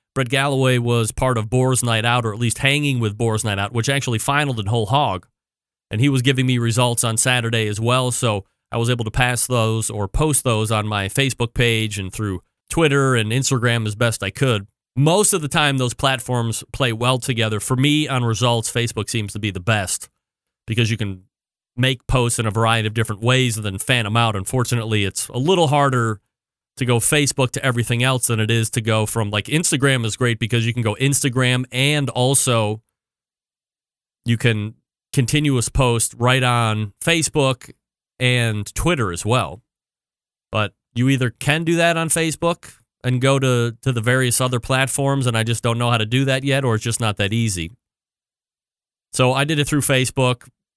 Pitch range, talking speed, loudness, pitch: 110-130 Hz, 195 wpm, -19 LUFS, 120 Hz